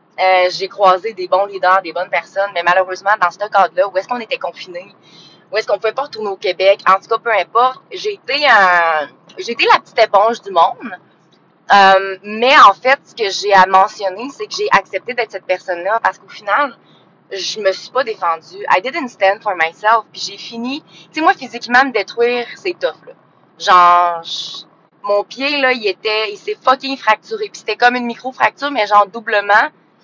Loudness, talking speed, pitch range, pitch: -14 LUFS, 205 wpm, 185-255 Hz, 205 Hz